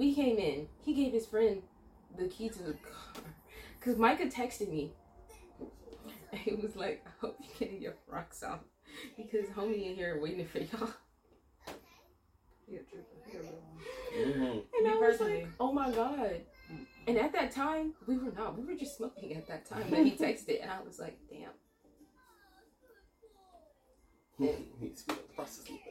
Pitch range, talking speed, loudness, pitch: 215-310 Hz, 155 wpm, -36 LUFS, 245 Hz